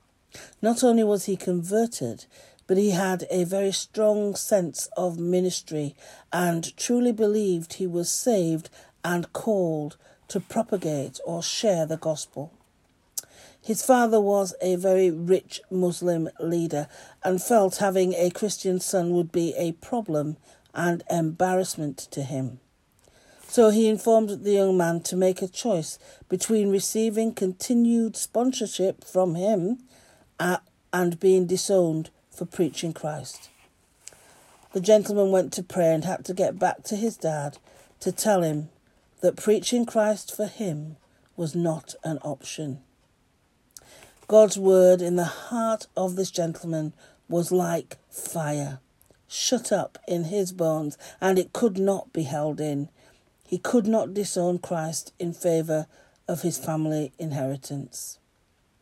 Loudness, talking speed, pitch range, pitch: -25 LUFS, 135 wpm, 160-200 Hz, 180 Hz